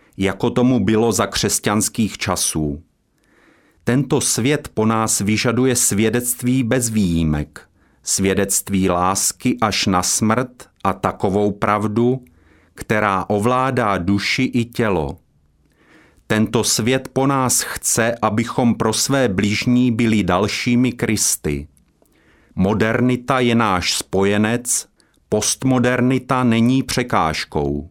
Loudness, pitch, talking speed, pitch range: -18 LUFS, 110 Hz, 100 wpm, 100-125 Hz